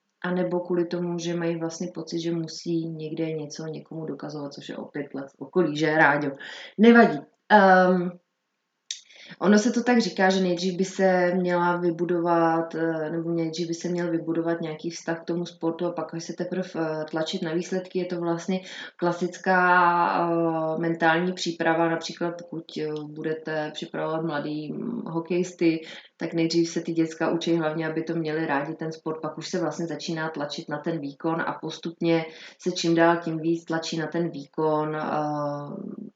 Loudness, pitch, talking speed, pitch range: -25 LUFS, 165 Hz, 165 wpm, 160-175 Hz